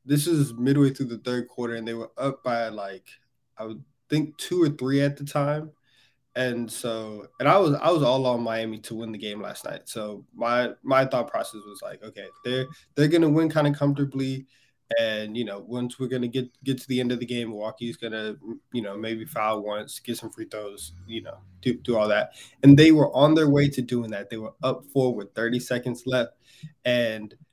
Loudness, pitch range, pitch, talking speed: -25 LUFS, 110-140 Hz, 125 Hz, 235 wpm